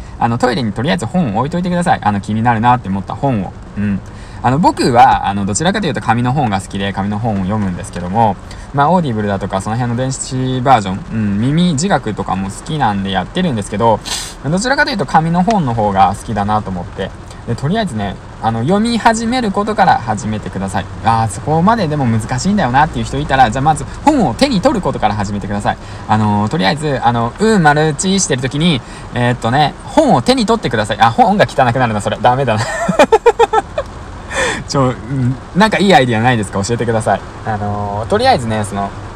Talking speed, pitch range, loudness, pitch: 455 characters per minute, 105-160 Hz, -14 LUFS, 115 Hz